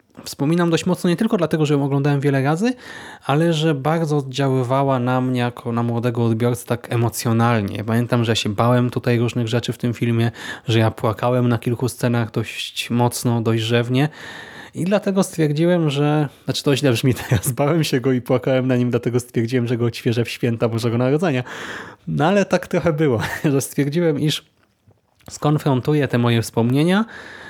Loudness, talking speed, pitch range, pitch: -19 LUFS, 175 wpm, 120-150 Hz, 130 Hz